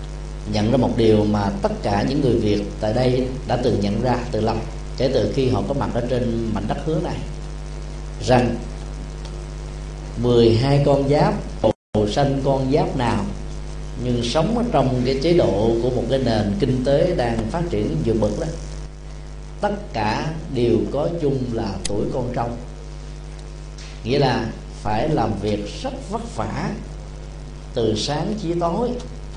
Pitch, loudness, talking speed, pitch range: 130 Hz, -21 LUFS, 160 wpm, 115-155 Hz